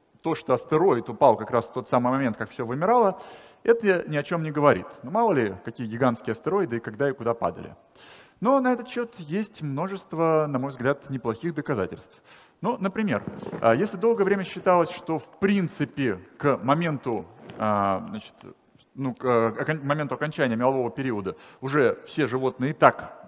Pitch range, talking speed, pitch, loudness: 125-190 Hz, 165 wpm, 145 Hz, -25 LUFS